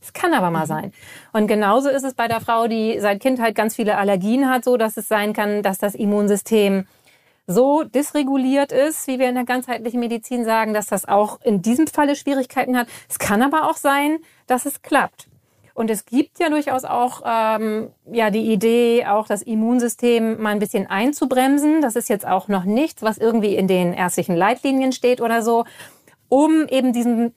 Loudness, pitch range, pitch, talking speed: -19 LUFS, 215-265 Hz, 235 Hz, 195 wpm